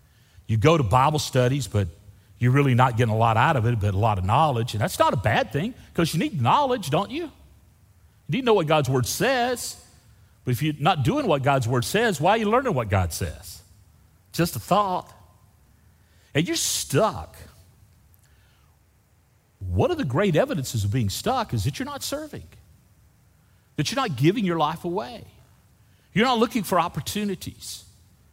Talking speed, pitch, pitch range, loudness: 185 wpm, 125 Hz, 100-160 Hz, -23 LUFS